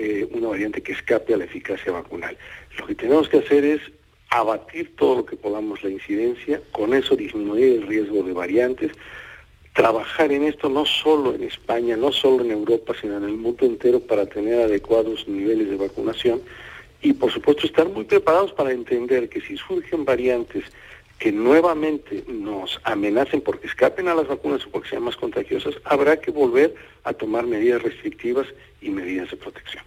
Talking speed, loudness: 175 wpm, -21 LUFS